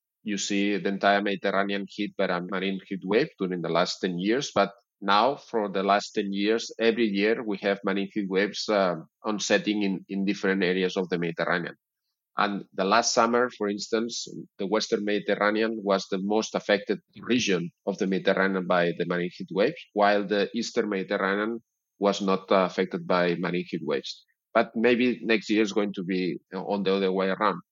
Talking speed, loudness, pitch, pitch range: 185 wpm, -26 LUFS, 100 Hz, 95-105 Hz